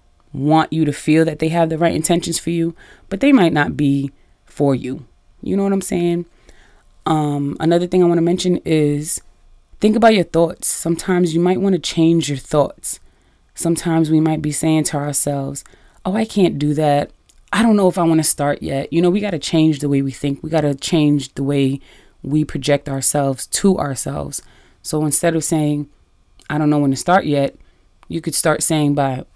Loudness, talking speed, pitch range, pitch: -17 LUFS, 200 wpm, 140-170 Hz, 155 Hz